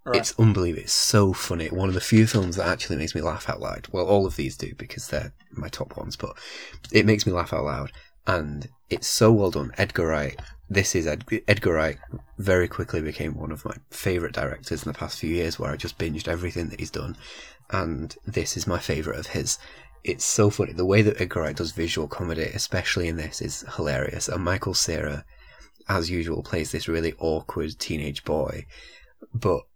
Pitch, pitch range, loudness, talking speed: 85 Hz, 80-100 Hz, -25 LUFS, 205 wpm